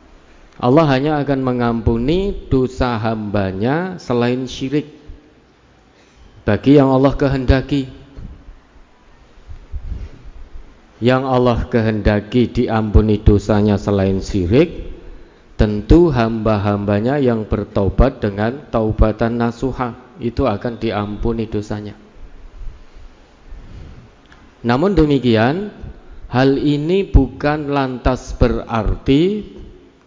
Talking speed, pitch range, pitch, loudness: 75 wpm, 105-130 Hz, 115 Hz, -17 LUFS